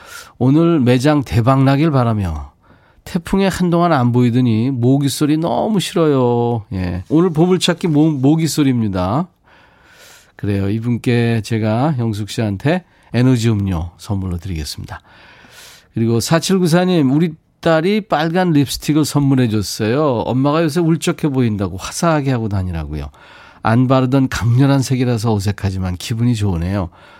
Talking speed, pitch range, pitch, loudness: 305 characters per minute, 105-155 Hz, 125 Hz, -16 LUFS